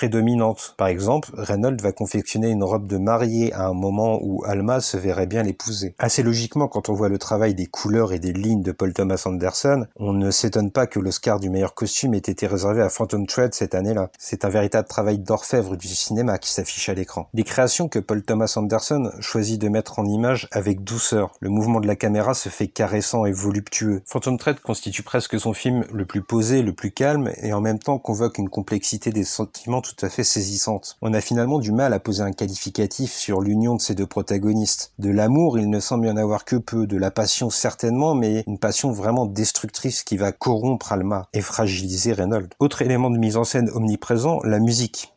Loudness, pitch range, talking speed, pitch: -22 LUFS, 100-115 Hz, 215 wpm, 110 Hz